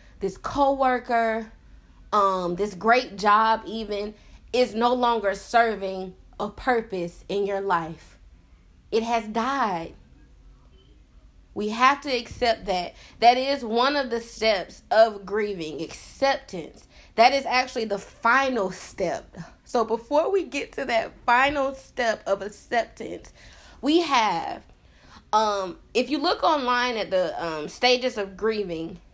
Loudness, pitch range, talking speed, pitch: -24 LUFS, 195-250 Hz, 130 wpm, 225 Hz